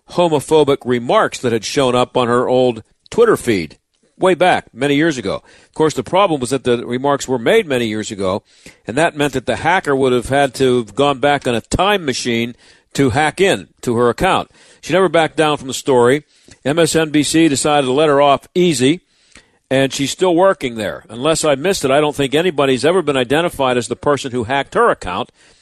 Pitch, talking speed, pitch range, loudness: 140 Hz, 210 wpm, 125-155 Hz, -15 LUFS